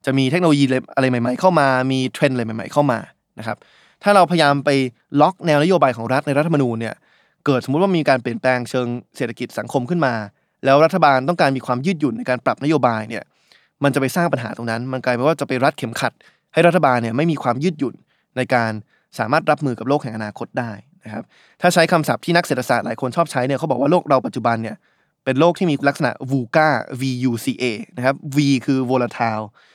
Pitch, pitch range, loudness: 135 Hz, 125-155 Hz, -19 LUFS